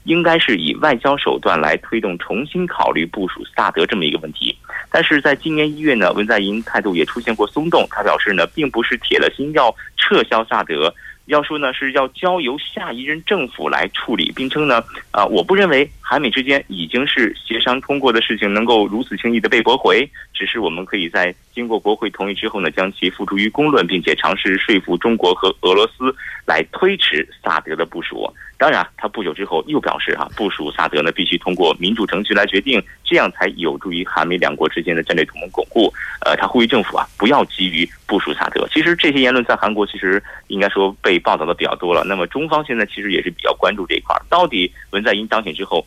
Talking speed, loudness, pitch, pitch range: 340 characters per minute, -17 LUFS, 120 Hz, 100-150 Hz